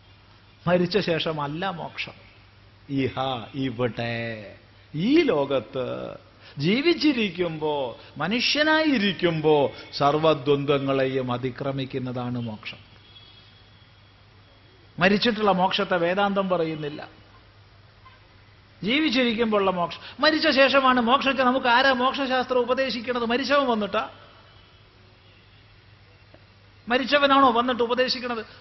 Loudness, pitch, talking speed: -23 LUFS, 145 Hz, 65 wpm